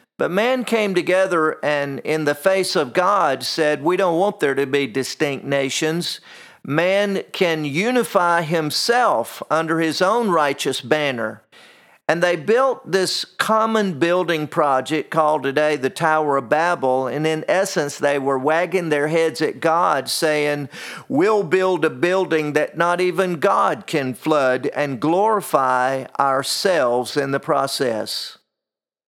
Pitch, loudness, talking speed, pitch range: 155 Hz, -19 LUFS, 140 wpm, 140-180 Hz